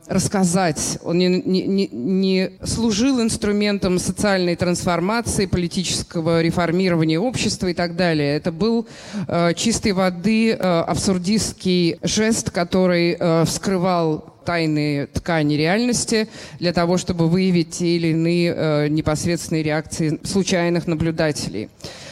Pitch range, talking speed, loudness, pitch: 165-190 Hz, 110 wpm, -20 LUFS, 175 Hz